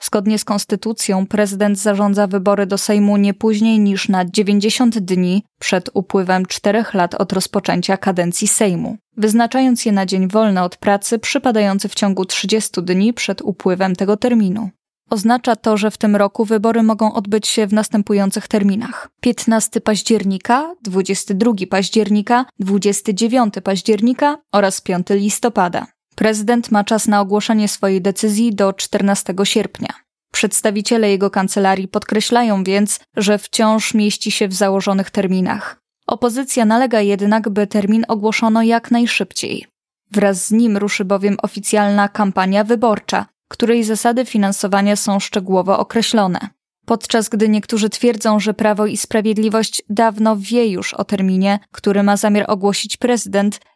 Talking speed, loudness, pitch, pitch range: 135 wpm, -16 LUFS, 210 Hz, 200-225 Hz